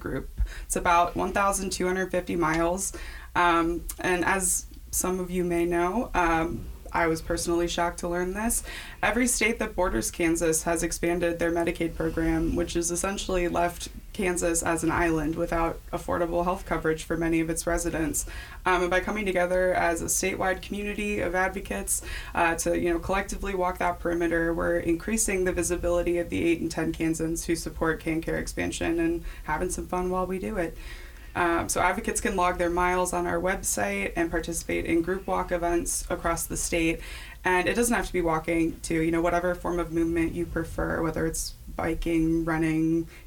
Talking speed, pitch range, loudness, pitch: 180 wpm, 165-180 Hz, -27 LUFS, 170 Hz